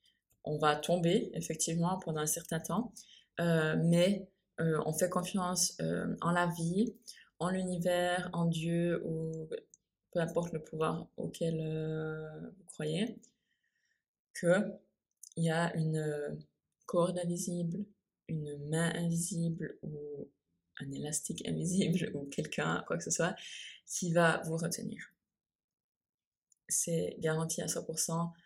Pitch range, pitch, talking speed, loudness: 160-185 Hz, 170 Hz, 120 wpm, -34 LUFS